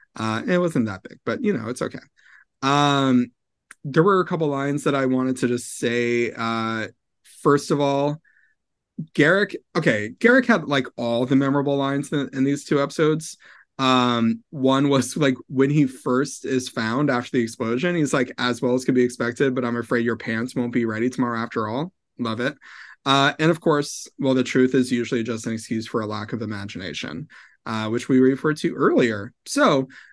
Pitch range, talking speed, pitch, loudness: 120-145 Hz, 195 wpm, 130 Hz, -22 LUFS